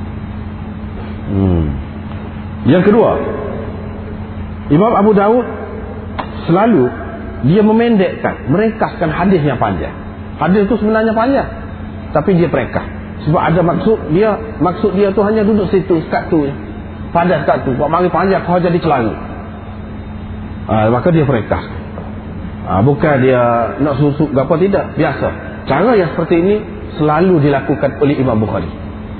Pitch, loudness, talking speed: 130 Hz, -14 LUFS, 130 wpm